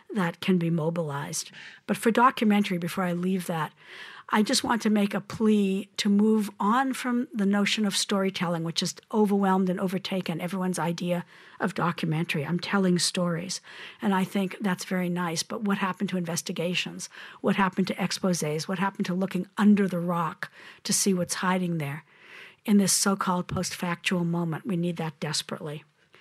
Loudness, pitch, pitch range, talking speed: -27 LUFS, 185 Hz, 175-200 Hz, 175 wpm